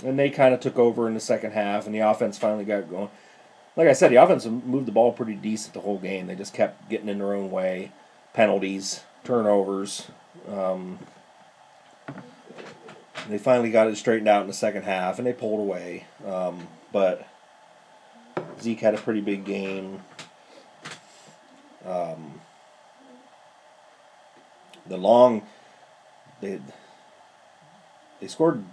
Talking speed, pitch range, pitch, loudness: 140 wpm, 95-115 Hz, 105 Hz, -24 LUFS